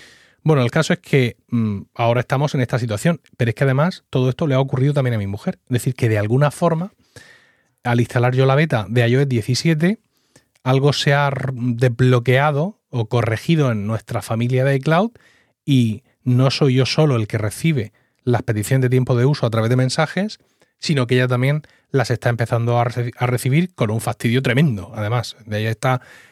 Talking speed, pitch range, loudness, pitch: 190 wpm, 120-145 Hz, -19 LUFS, 130 Hz